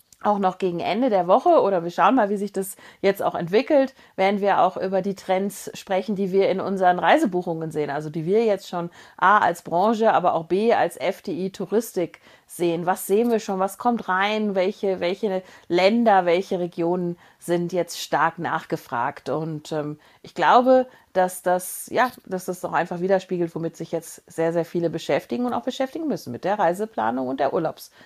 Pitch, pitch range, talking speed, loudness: 185 Hz, 170-200 Hz, 190 wpm, -22 LUFS